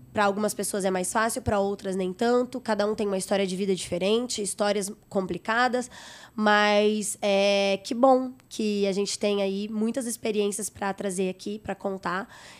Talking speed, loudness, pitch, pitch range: 170 wpm, -26 LUFS, 205 Hz, 195-220 Hz